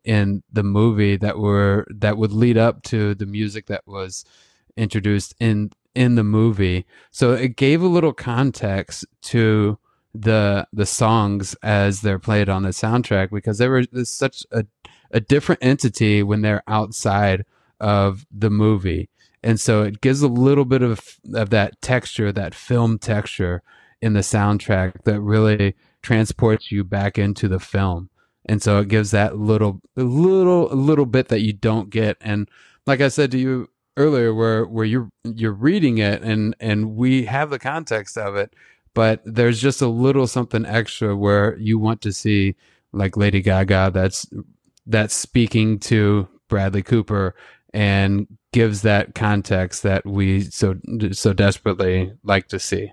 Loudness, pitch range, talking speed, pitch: -19 LUFS, 100-115 Hz, 160 wpm, 110 Hz